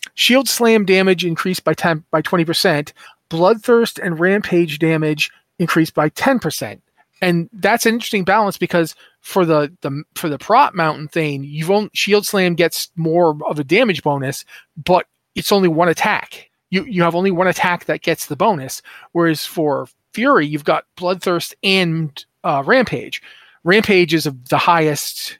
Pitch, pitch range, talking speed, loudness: 175 Hz, 160-195 Hz, 165 wpm, -16 LUFS